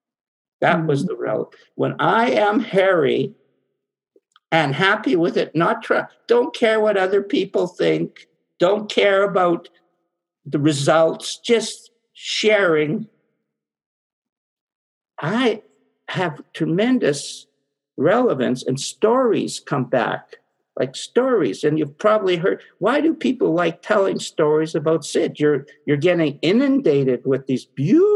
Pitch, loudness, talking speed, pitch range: 180 Hz, -19 LUFS, 120 wpm, 150-225 Hz